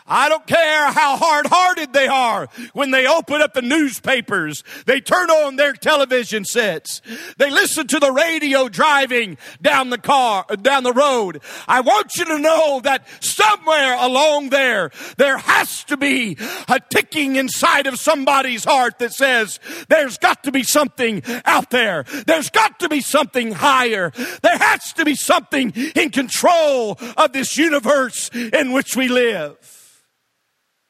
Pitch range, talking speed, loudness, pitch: 255-305 Hz, 155 wpm, -16 LUFS, 275 Hz